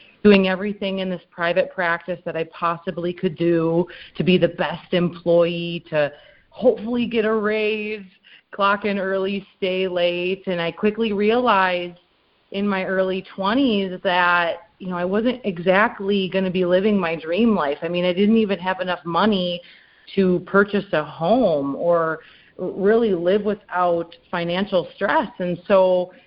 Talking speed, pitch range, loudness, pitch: 155 wpm, 175-205 Hz, -21 LUFS, 185 Hz